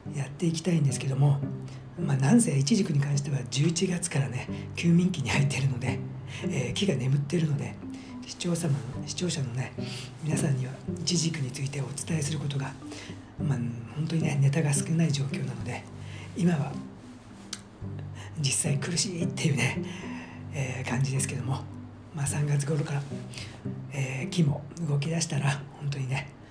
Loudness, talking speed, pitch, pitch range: -29 LUFS, 320 characters per minute, 140 Hz, 130-155 Hz